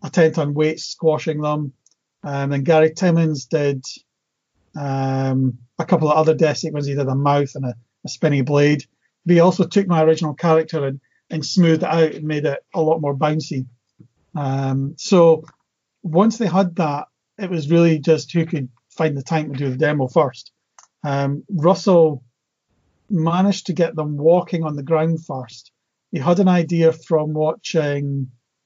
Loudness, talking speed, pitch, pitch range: -19 LUFS, 175 wpm, 155 Hz, 140-165 Hz